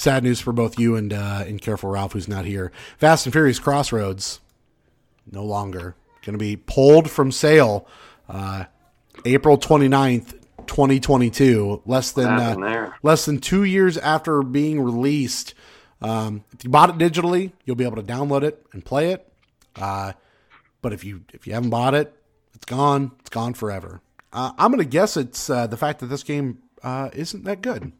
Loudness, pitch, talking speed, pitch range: -20 LUFS, 125 Hz, 185 wpm, 105-145 Hz